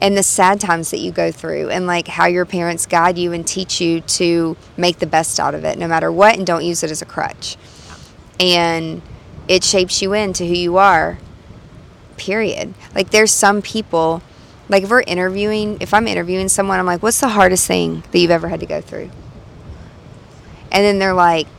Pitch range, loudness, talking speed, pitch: 170-195 Hz, -15 LUFS, 205 wpm, 180 Hz